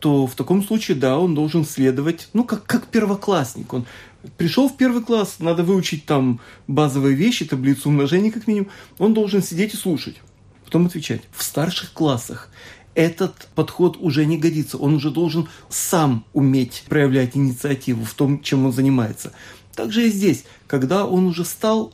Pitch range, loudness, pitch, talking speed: 130-185 Hz, -20 LUFS, 155 Hz, 165 wpm